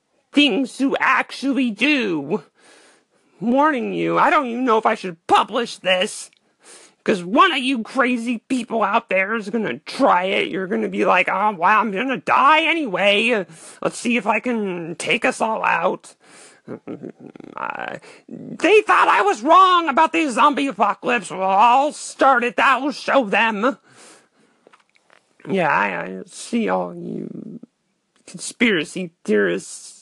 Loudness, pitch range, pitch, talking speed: -18 LUFS, 200-275 Hz, 235 Hz, 150 wpm